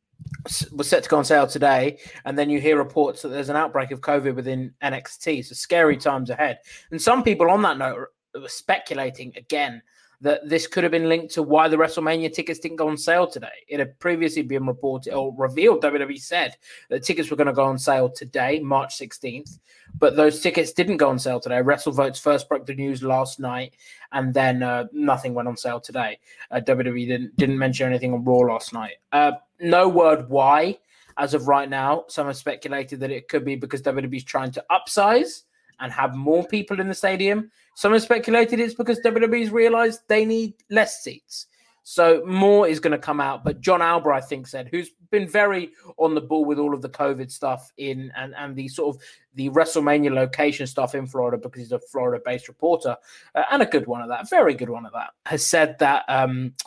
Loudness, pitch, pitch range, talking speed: -22 LUFS, 145 Hz, 135-165 Hz, 215 wpm